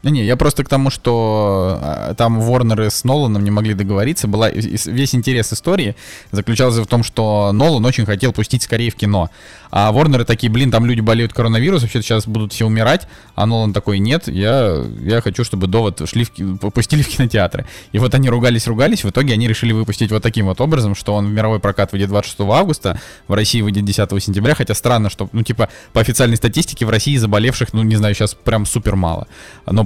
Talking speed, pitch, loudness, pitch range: 200 wpm, 115 Hz, -16 LUFS, 105-125 Hz